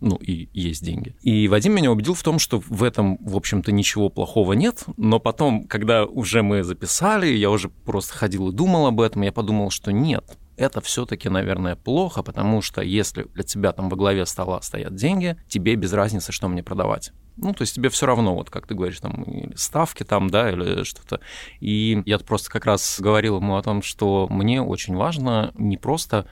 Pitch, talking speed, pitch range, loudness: 105 Hz, 205 wpm, 95-115 Hz, -22 LUFS